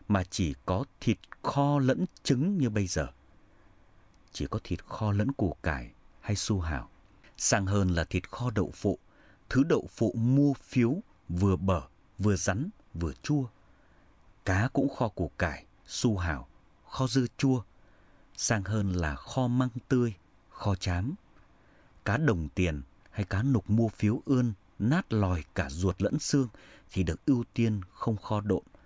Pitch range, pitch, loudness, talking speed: 90-125 Hz, 105 Hz, -30 LUFS, 160 wpm